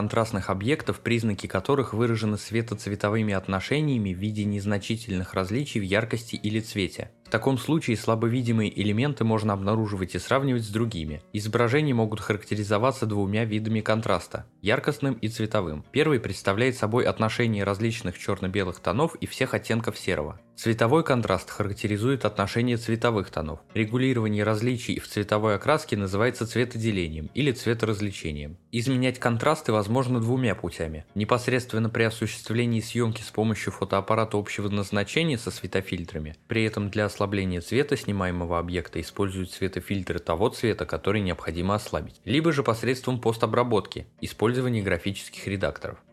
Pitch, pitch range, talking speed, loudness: 110 Hz, 100-120 Hz, 125 wpm, -26 LUFS